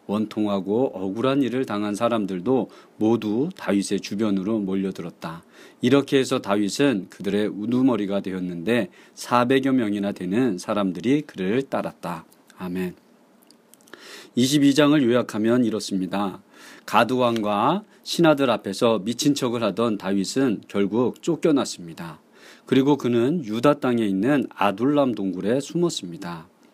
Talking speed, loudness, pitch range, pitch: 285 characters per minute, -23 LUFS, 100-130 Hz, 110 Hz